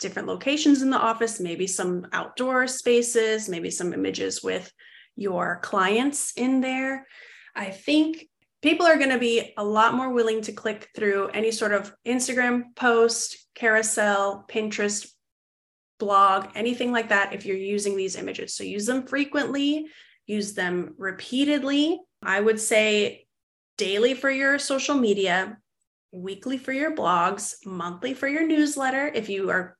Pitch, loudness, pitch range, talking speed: 225 Hz, -24 LUFS, 200-265 Hz, 145 wpm